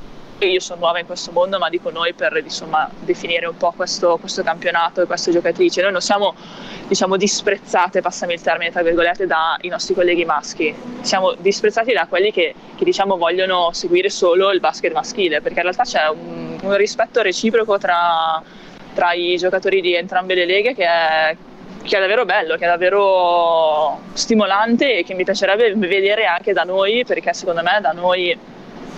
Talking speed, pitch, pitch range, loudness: 180 wpm, 185 Hz, 170-205 Hz, -17 LUFS